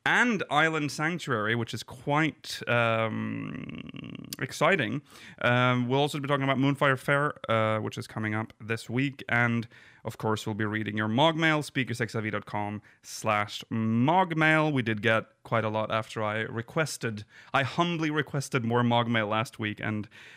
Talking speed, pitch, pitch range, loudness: 150 wpm, 120 Hz, 110-140 Hz, -28 LUFS